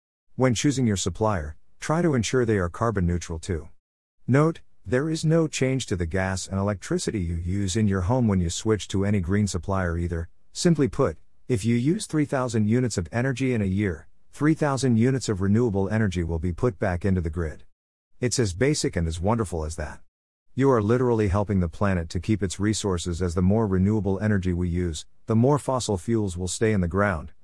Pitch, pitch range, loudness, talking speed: 100 Hz, 90-125 Hz, -25 LUFS, 205 wpm